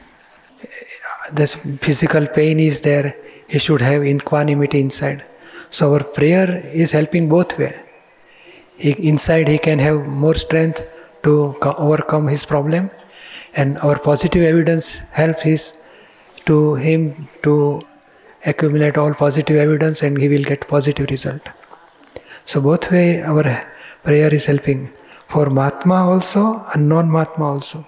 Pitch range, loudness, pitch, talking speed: 145-160 Hz, -16 LUFS, 150 Hz, 135 wpm